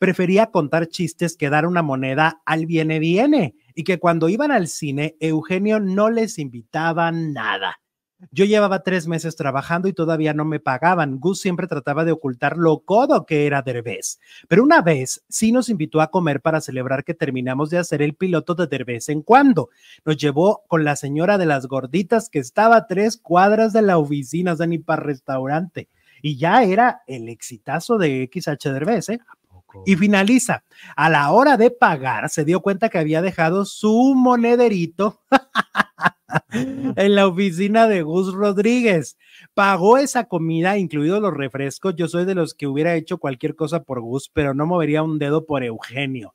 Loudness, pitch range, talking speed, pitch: -19 LUFS, 150-195 Hz, 170 wpm, 165 Hz